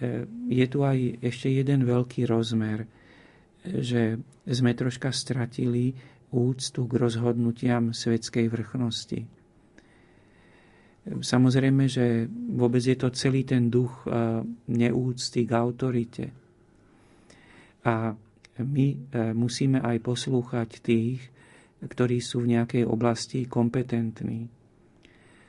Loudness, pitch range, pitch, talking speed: -27 LUFS, 115-130 Hz, 120 Hz, 90 wpm